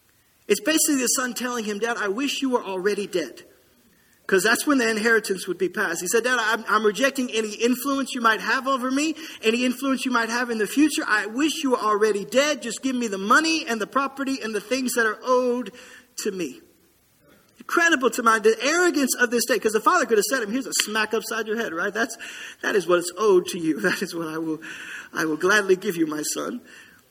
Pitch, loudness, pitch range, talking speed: 235 Hz, -22 LUFS, 210-270 Hz, 235 wpm